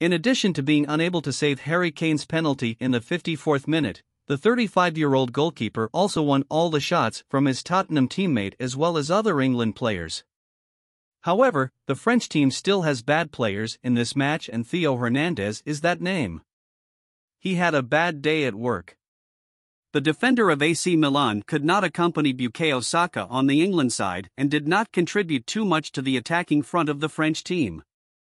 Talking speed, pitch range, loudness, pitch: 180 wpm, 130-170 Hz, -23 LUFS, 150 Hz